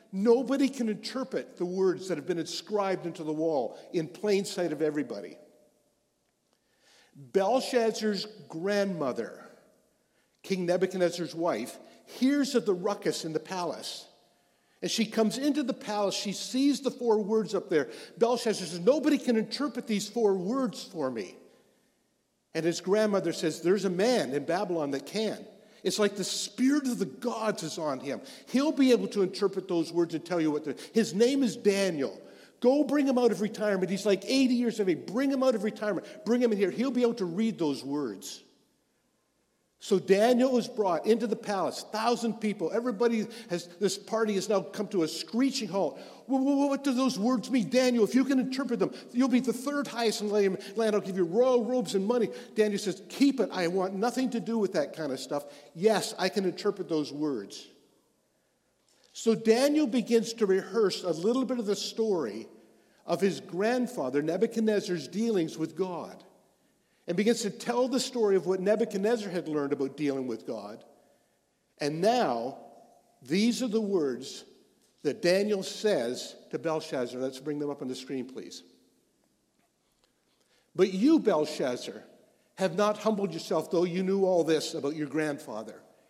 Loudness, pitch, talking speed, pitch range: -29 LUFS, 205 Hz, 175 wpm, 180-235 Hz